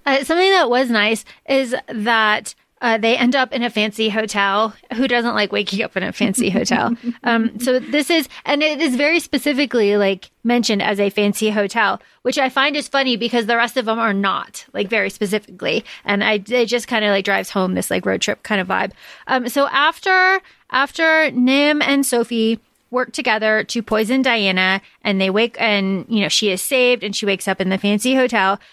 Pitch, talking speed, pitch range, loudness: 235 Hz, 205 wpm, 210-265 Hz, -17 LUFS